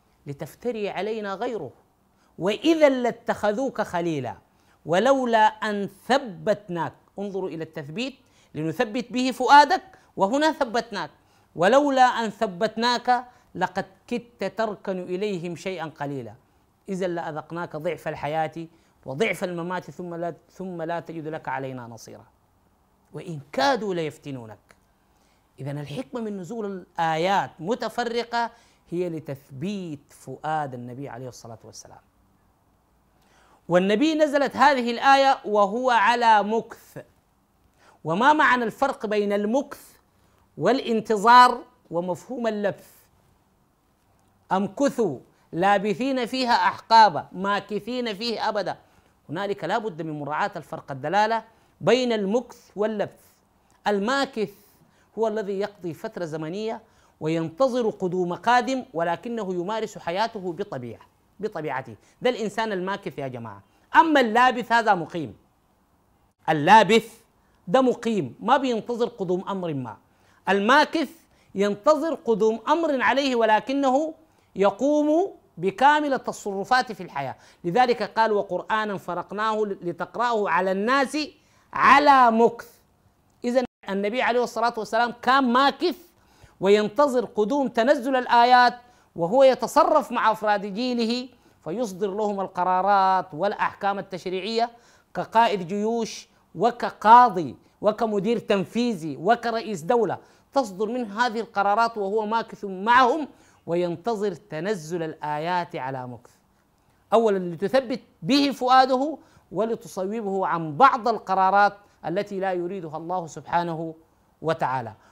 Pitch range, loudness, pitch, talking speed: 175-240 Hz, -23 LUFS, 210 Hz, 100 wpm